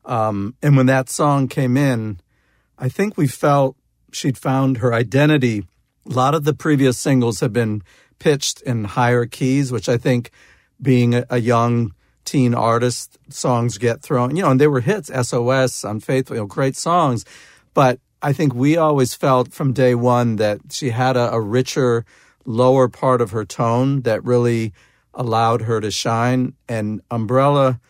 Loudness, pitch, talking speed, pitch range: -18 LUFS, 125 Hz, 170 wpm, 115-135 Hz